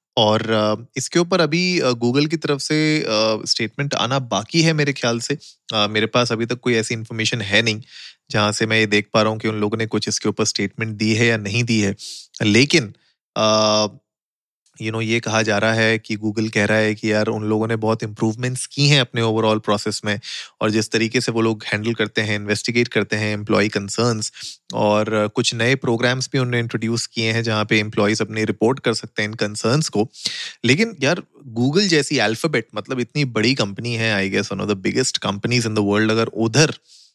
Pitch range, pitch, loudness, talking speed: 105-125 Hz, 110 Hz, -19 LUFS, 210 wpm